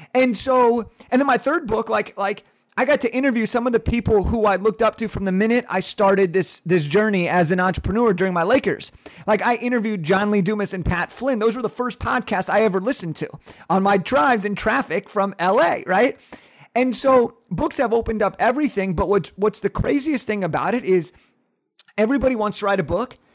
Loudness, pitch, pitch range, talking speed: -20 LUFS, 215 Hz, 195-245 Hz, 215 wpm